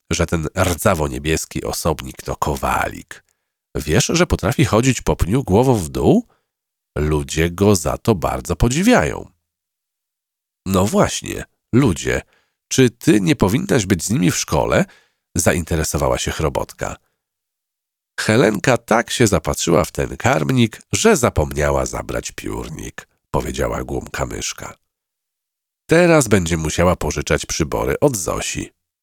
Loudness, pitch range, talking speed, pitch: -18 LUFS, 80-115 Hz, 120 wpm, 90 Hz